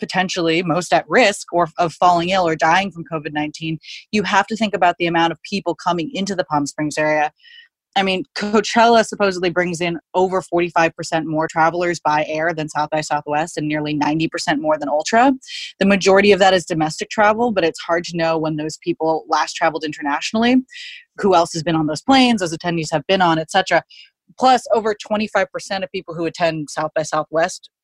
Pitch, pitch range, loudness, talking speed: 175 Hz, 160-200 Hz, -18 LUFS, 210 wpm